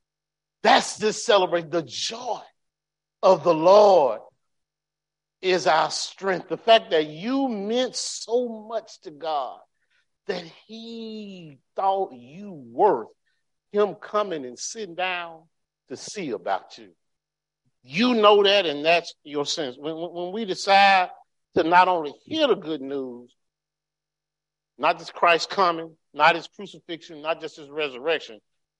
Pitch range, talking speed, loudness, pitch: 155-210 Hz, 130 wpm, -23 LUFS, 175 Hz